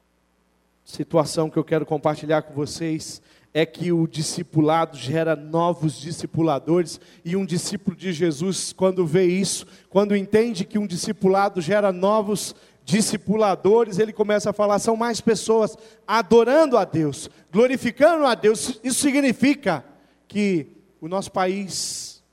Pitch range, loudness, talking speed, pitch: 160-215 Hz, -22 LUFS, 130 wpm, 185 Hz